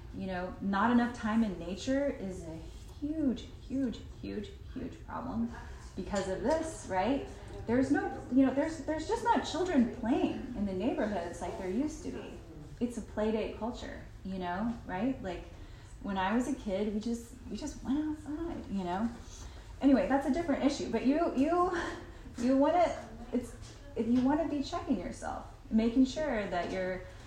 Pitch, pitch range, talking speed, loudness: 260 Hz, 215-295 Hz, 175 wpm, -33 LUFS